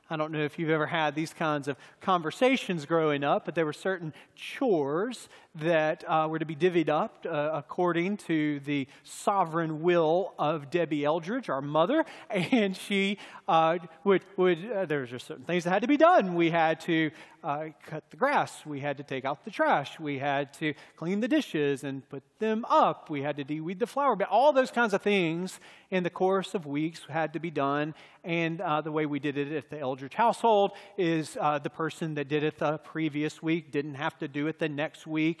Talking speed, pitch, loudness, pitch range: 215 wpm, 160 Hz, -29 LUFS, 150-185 Hz